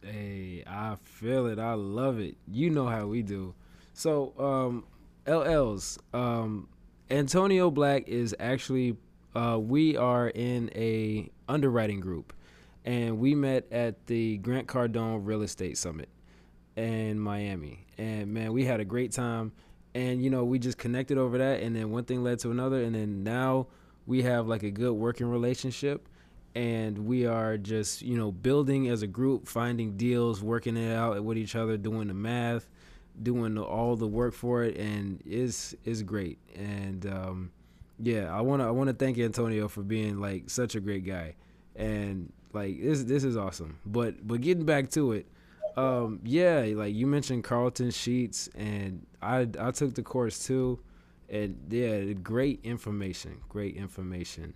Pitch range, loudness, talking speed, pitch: 100-125 Hz, -31 LUFS, 165 wpm, 115 Hz